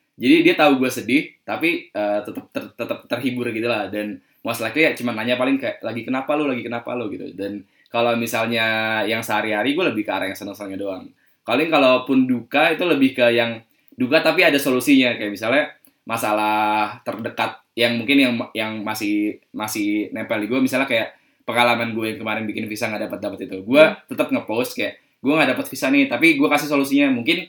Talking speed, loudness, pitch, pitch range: 195 wpm, -20 LUFS, 120 Hz, 110-150 Hz